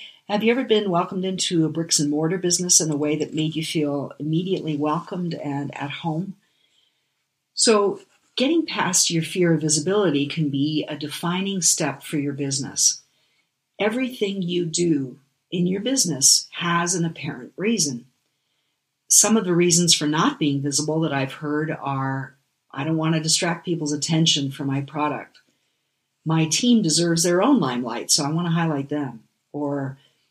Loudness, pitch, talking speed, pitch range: -21 LUFS, 155 Hz, 165 wpm, 145-175 Hz